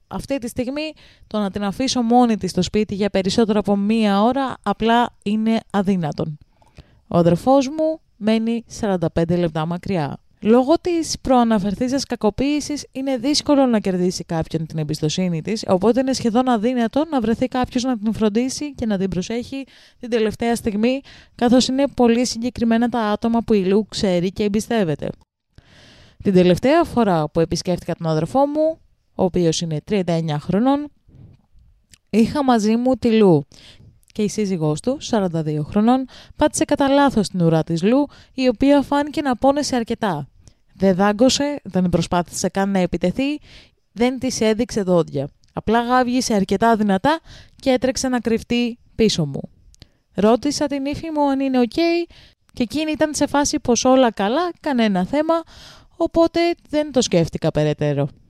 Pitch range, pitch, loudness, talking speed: 185-265 Hz, 230 Hz, -19 LUFS, 155 wpm